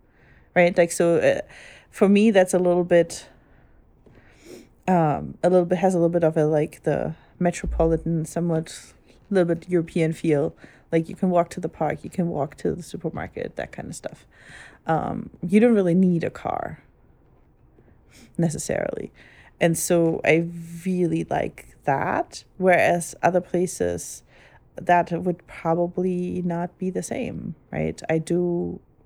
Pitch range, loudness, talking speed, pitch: 165-180 Hz, -23 LUFS, 150 wpm, 175 Hz